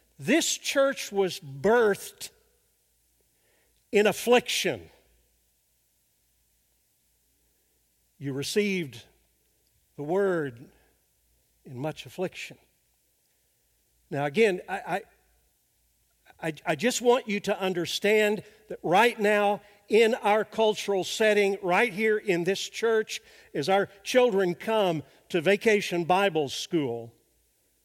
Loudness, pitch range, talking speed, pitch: -26 LUFS, 140-215 Hz, 95 wpm, 195 Hz